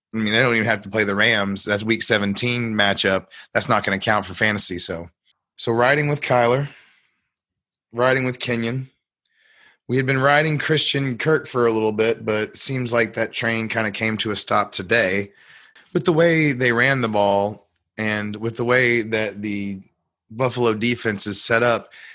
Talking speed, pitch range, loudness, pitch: 185 wpm, 105-125 Hz, -20 LUFS, 115 Hz